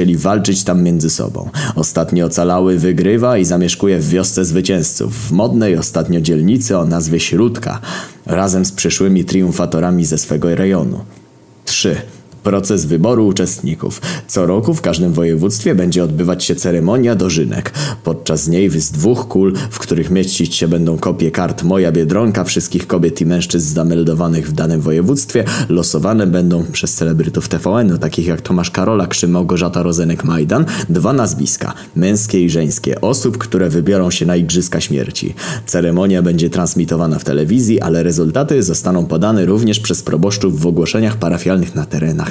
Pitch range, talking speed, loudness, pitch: 85-95 Hz, 150 wpm, -14 LUFS, 85 Hz